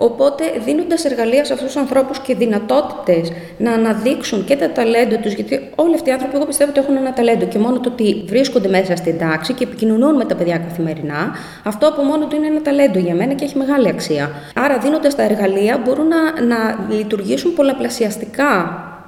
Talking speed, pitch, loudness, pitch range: 195 wpm, 245 Hz, -16 LUFS, 205-280 Hz